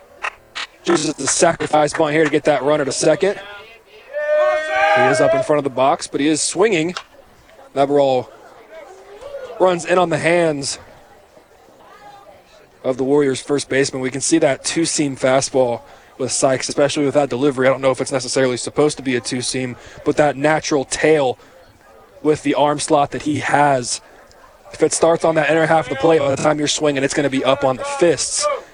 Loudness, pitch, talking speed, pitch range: -17 LUFS, 150 Hz, 195 wpm, 135-160 Hz